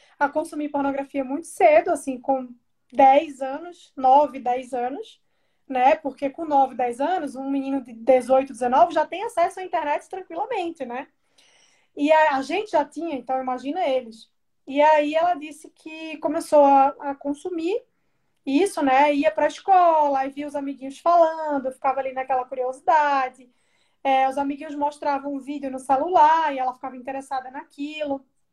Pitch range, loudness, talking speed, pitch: 265-315 Hz, -22 LUFS, 155 wpm, 285 Hz